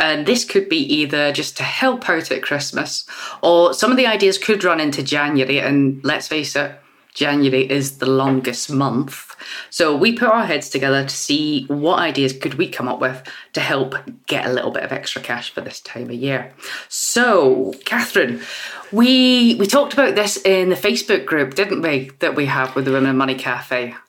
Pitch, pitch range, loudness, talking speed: 145 Hz, 135-205 Hz, -17 LUFS, 195 wpm